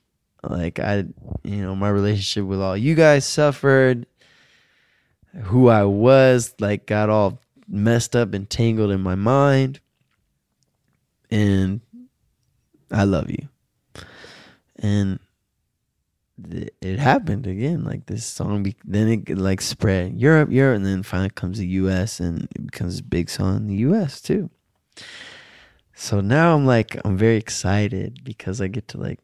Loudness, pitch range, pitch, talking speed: -20 LUFS, 95-125 Hz, 105 Hz, 140 wpm